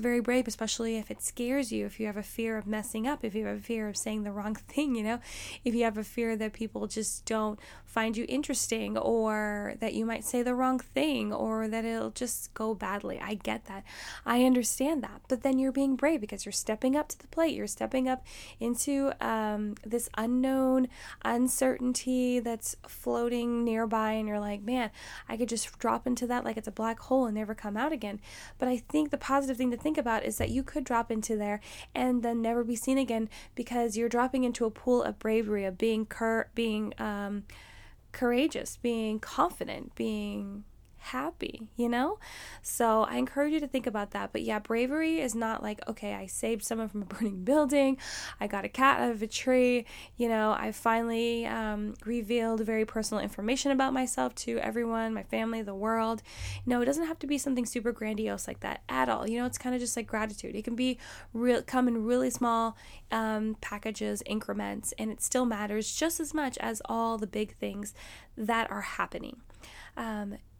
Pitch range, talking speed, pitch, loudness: 215-255 Hz, 205 wpm, 230 Hz, -31 LUFS